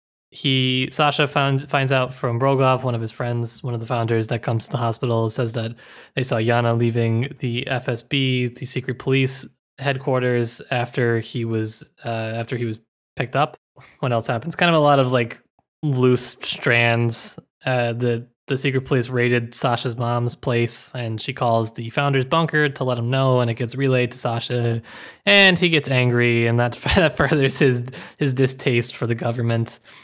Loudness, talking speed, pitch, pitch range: -20 LUFS, 180 wpm, 125 Hz, 120-135 Hz